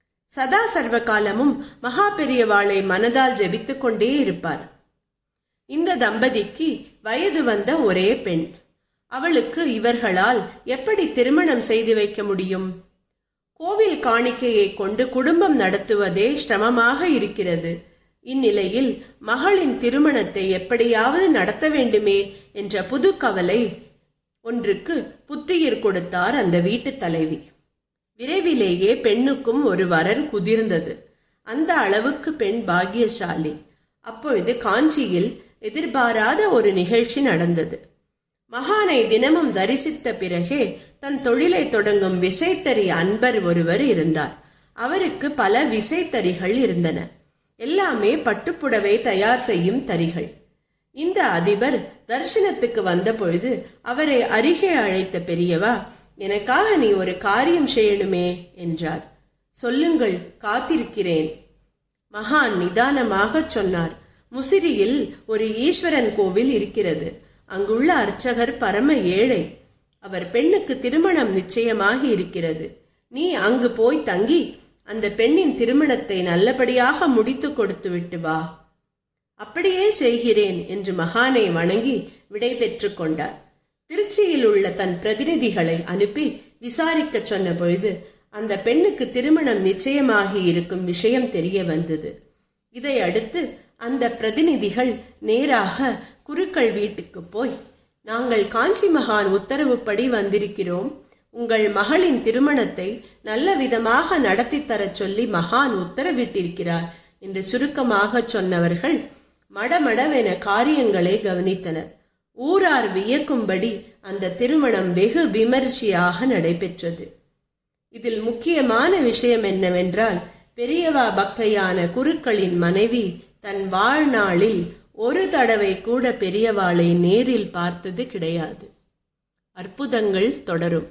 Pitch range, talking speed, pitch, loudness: 195-275 Hz, 90 wpm, 230 Hz, -20 LUFS